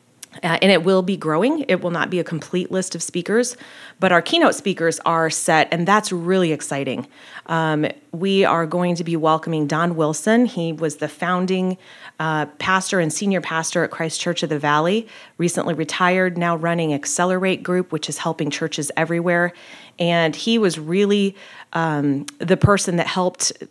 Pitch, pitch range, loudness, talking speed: 170 Hz, 160-185 Hz, -20 LUFS, 175 wpm